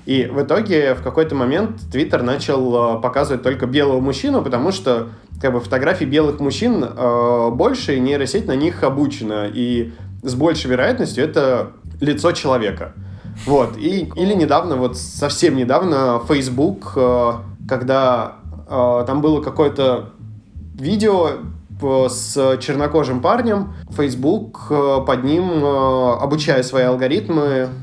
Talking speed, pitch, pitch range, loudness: 125 wpm, 130 Hz, 120-140 Hz, -17 LUFS